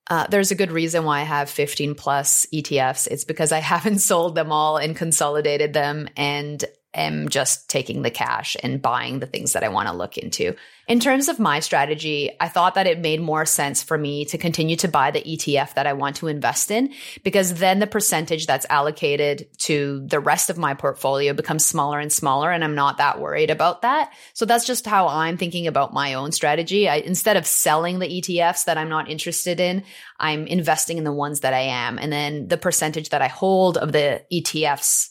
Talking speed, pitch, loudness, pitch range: 215 wpm, 155 Hz, -21 LUFS, 145-175 Hz